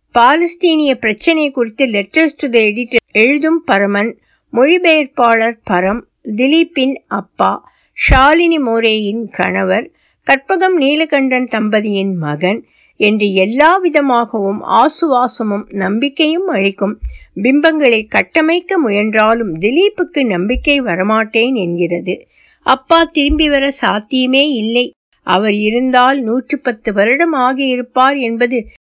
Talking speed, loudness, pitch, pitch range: 90 wpm, -13 LUFS, 250 Hz, 215-295 Hz